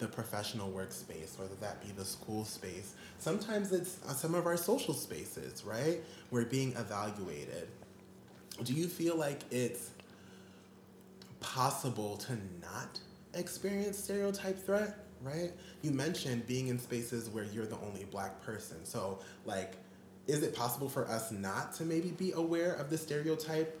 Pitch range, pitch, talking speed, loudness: 105-170 Hz, 125 Hz, 145 wpm, -38 LUFS